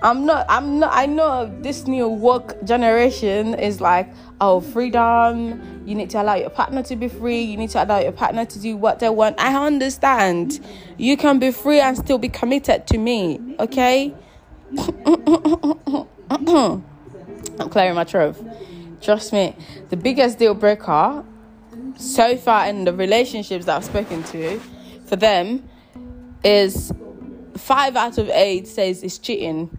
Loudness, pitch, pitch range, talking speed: -19 LUFS, 230 Hz, 200-265 Hz, 155 wpm